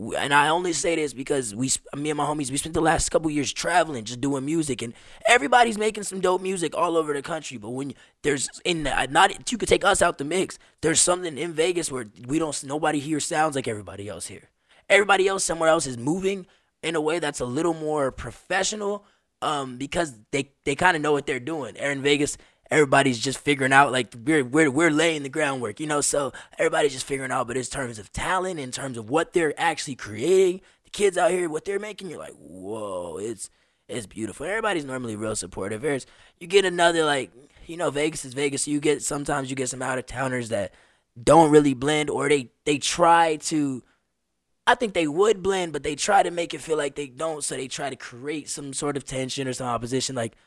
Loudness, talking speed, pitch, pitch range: -24 LUFS, 225 wpm, 150 Hz, 135-170 Hz